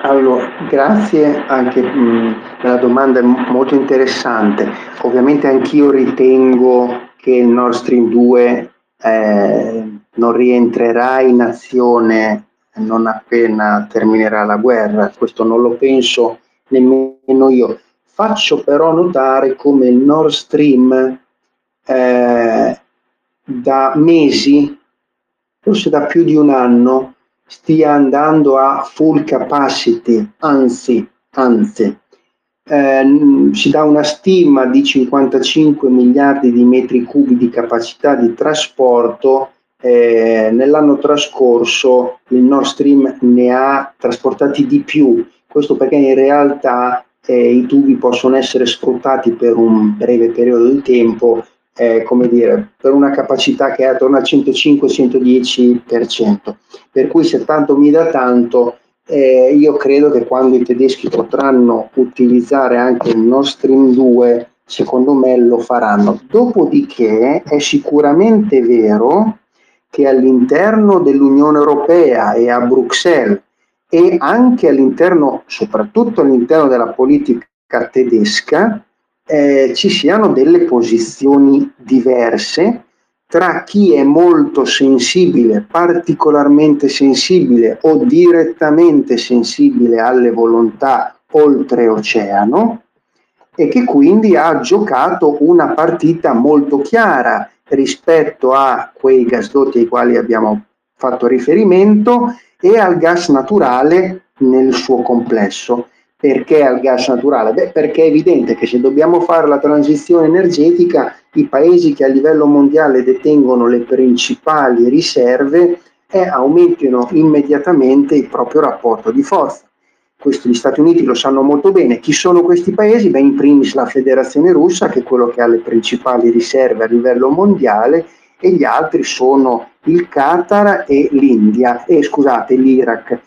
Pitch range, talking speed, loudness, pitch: 120-150 Hz, 120 wpm, -11 LUFS, 135 Hz